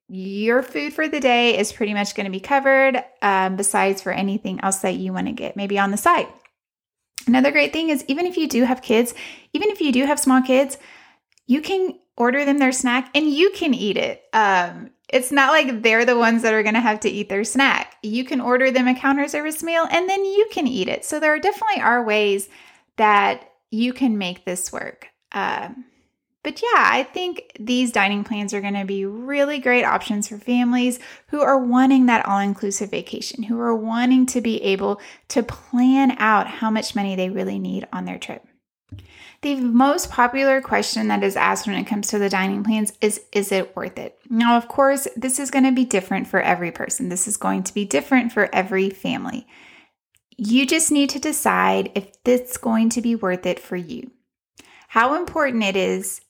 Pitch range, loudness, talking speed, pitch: 205-270 Hz, -20 LUFS, 210 wpm, 240 Hz